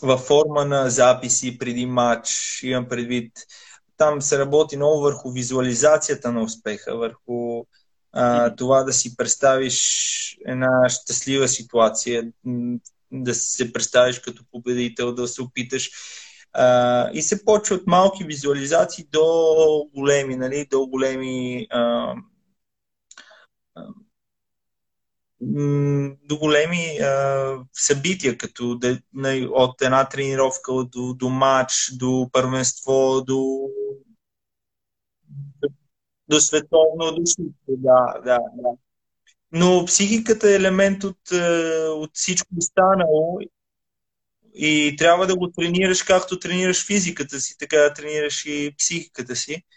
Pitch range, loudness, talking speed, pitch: 125-160 Hz, -20 LUFS, 110 wpm, 135 Hz